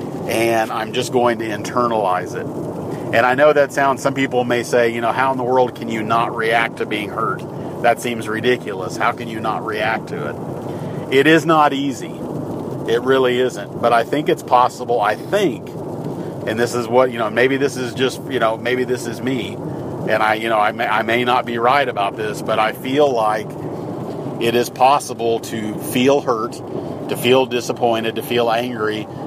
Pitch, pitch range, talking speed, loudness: 120 Hz, 115-130 Hz, 200 wpm, -18 LUFS